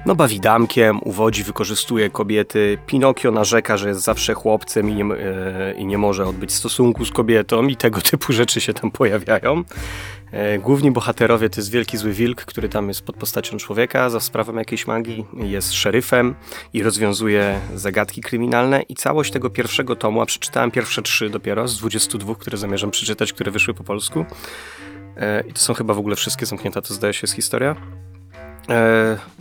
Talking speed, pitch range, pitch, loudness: 175 wpm, 100-115 Hz, 110 Hz, -19 LUFS